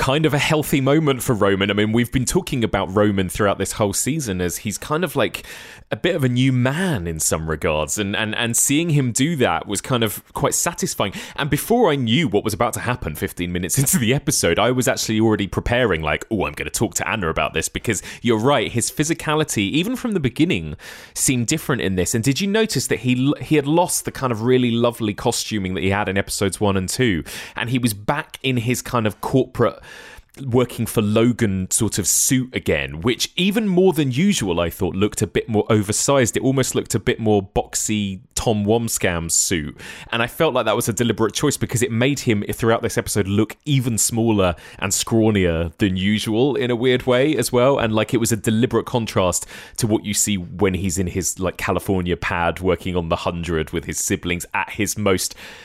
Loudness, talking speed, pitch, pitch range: -20 LUFS, 220 wpm, 115 Hz, 100-130 Hz